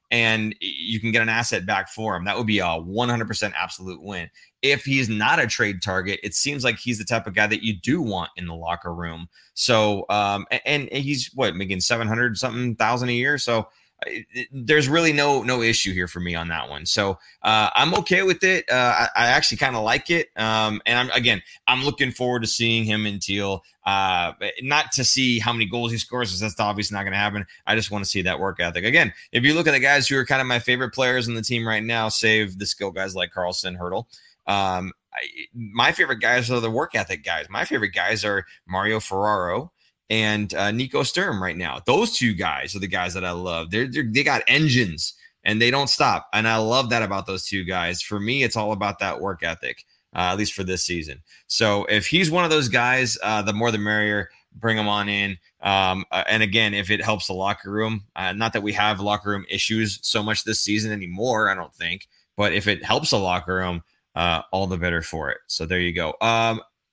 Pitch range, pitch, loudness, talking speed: 95-120 Hz, 110 Hz, -21 LUFS, 235 wpm